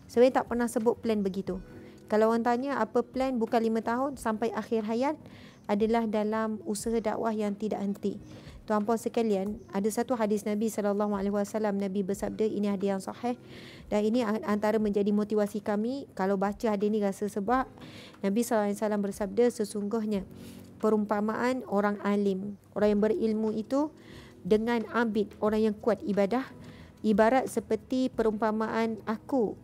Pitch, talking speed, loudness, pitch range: 215 Hz, 155 wpm, -29 LUFS, 205-230 Hz